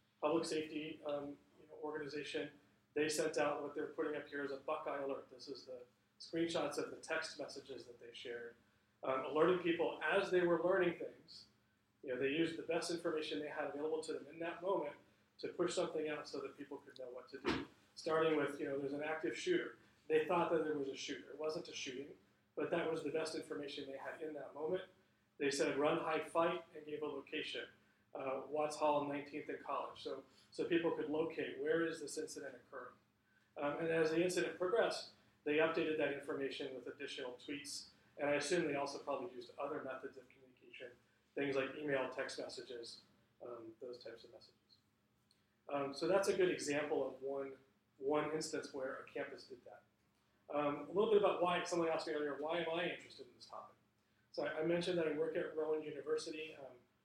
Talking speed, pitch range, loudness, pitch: 205 wpm, 135-160 Hz, -41 LUFS, 150 Hz